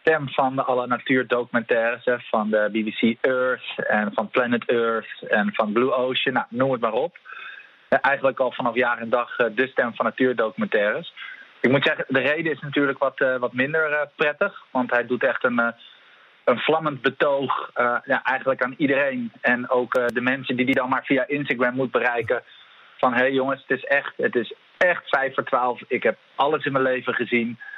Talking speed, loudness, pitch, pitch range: 190 wpm, -22 LUFS, 130 Hz, 120-140 Hz